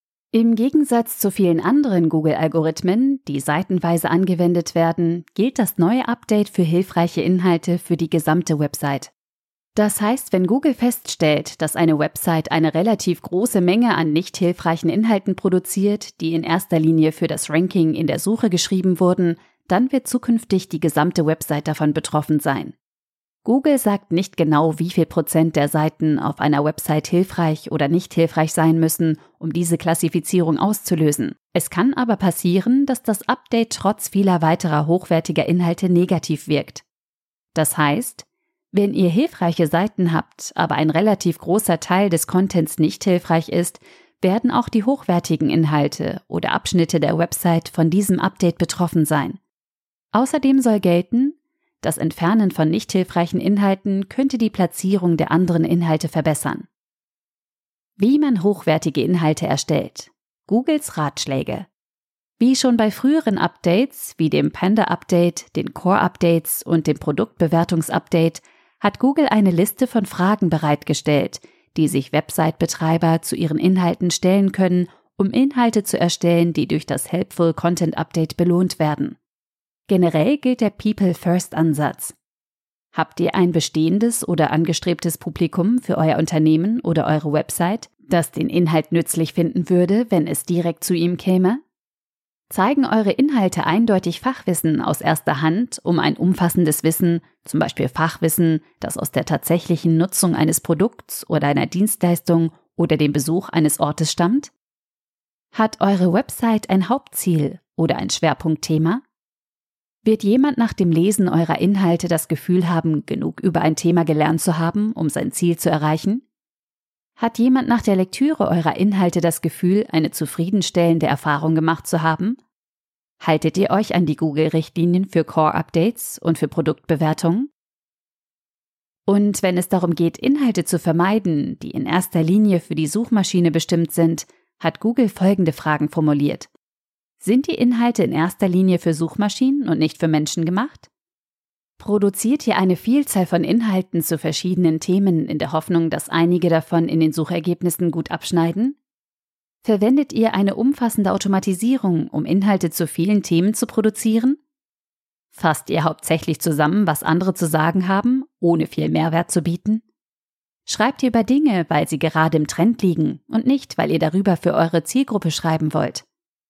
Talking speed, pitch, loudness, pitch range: 145 wpm, 175 Hz, -19 LUFS, 160-205 Hz